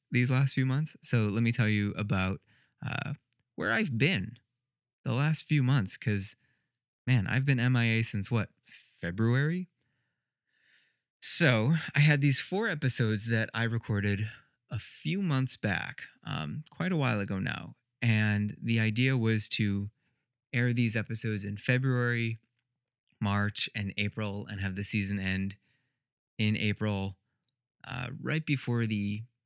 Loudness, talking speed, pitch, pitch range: -28 LUFS, 140 wpm, 120 Hz, 105-130 Hz